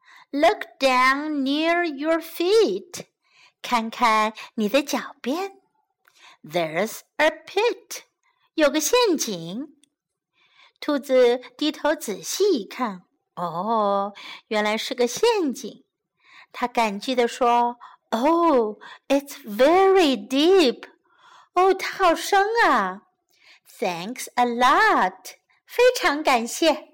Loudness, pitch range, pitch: -22 LUFS, 240-365 Hz, 290 Hz